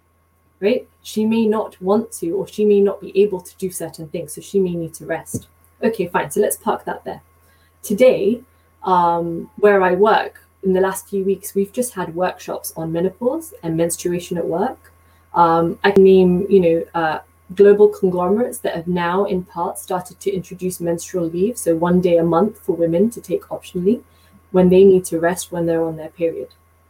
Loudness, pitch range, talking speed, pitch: -18 LUFS, 165-200 Hz, 195 wpm, 180 Hz